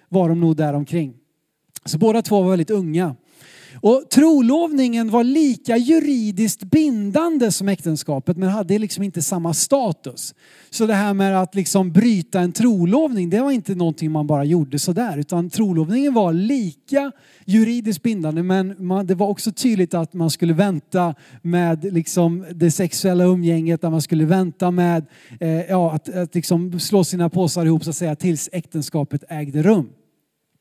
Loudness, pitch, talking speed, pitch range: -19 LUFS, 180 Hz, 165 wpm, 165-215 Hz